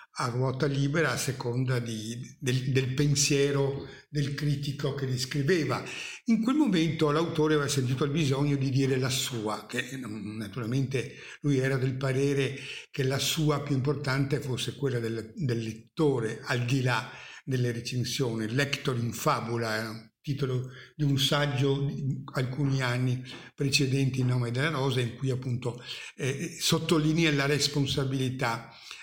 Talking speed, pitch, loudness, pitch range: 145 wpm, 135 Hz, -29 LUFS, 125-145 Hz